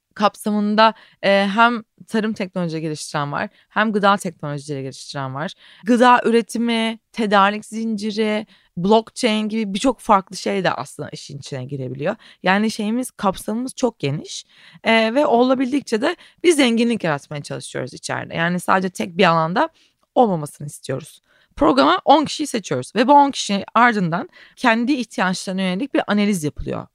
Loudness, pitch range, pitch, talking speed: -19 LUFS, 180-235 Hz, 210 Hz, 140 wpm